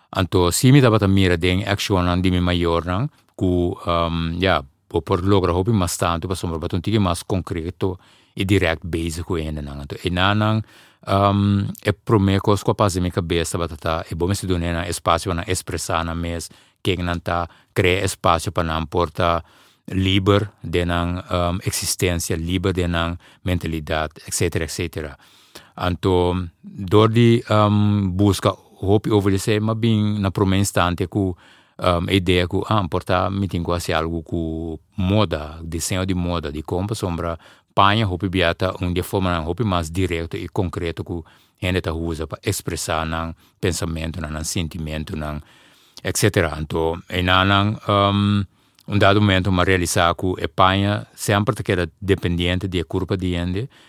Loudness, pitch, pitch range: -21 LUFS, 90 Hz, 85-100 Hz